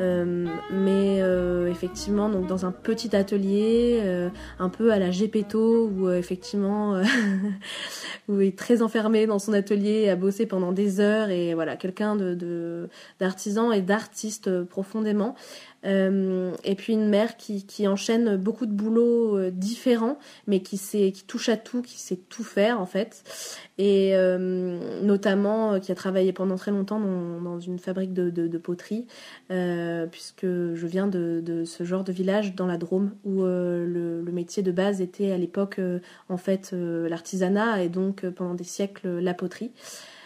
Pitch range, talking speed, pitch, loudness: 180-210 Hz, 180 wpm, 195 Hz, -26 LUFS